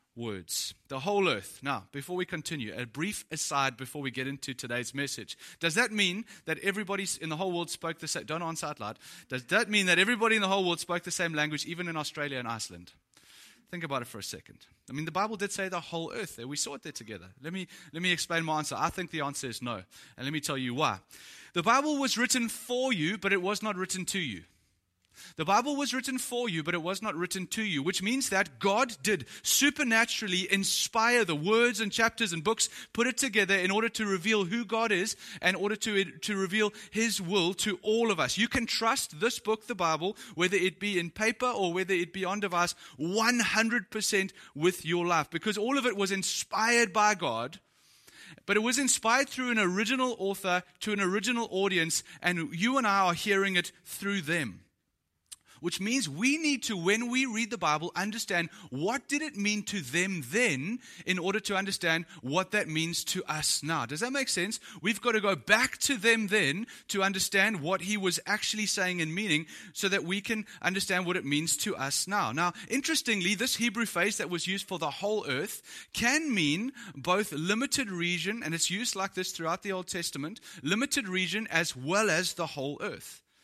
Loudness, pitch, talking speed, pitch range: -29 LUFS, 190 Hz, 215 wpm, 165-220 Hz